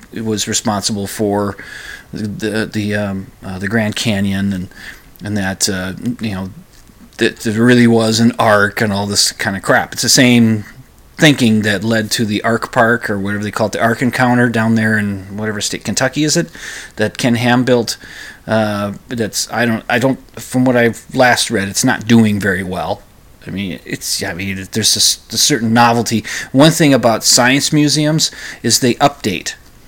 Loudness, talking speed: -14 LUFS, 185 wpm